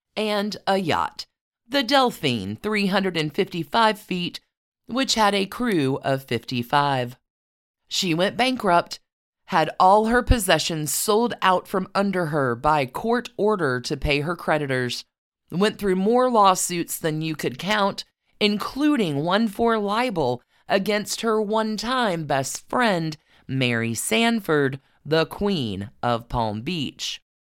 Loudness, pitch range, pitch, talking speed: -22 LUFS, 140-215 Hz, 180 Hz, 125 wpm